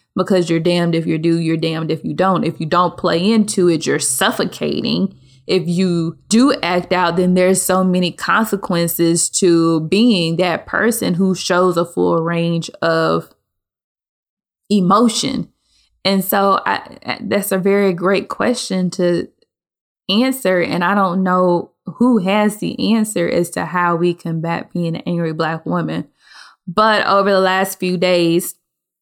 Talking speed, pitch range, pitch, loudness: 155 wpm, 170-195 Hz, 180 Hz, -16 LUFS